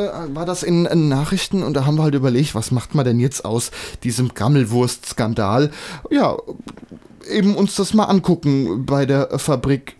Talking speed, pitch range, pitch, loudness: 160 wpm, 125-175 Hz, 140 Hz, -18 LUFS